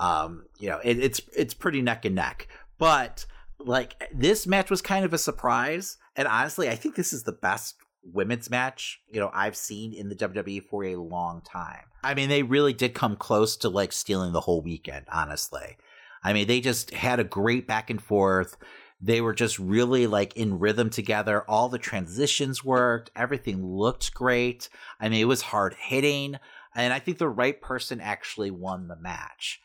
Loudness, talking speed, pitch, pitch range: -26 LUFS, 190 wpm, 115 Hz, 100-130 Hz